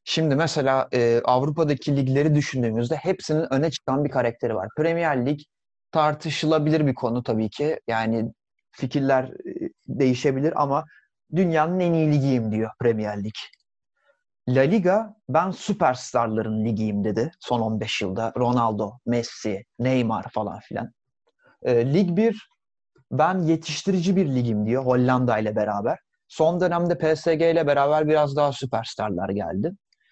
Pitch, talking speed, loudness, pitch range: 135 Hz, 130 wpm, -23 LUFS, 115-160 Hz